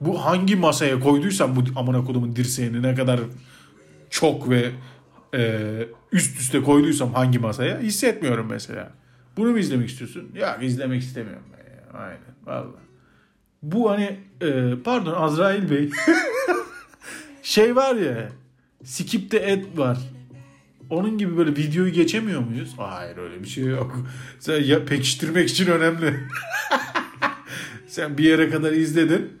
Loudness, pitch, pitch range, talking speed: -22 LUFS, 140 Hz, 125-175 Hz, 130 wpm